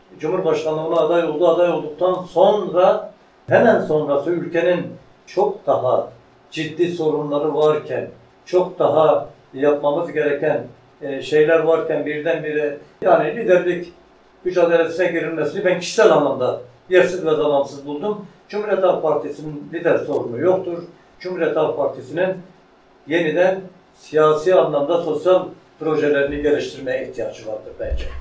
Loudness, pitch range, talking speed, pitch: -19 LUFS, 150-180 Hz, 110 wpm, 165 Hz